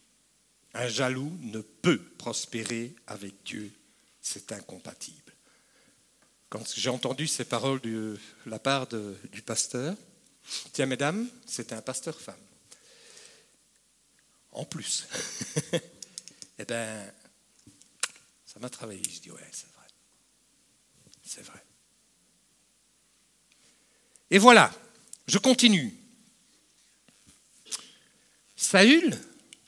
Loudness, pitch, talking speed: -27 LUFS, 140 Hz, 90 wpm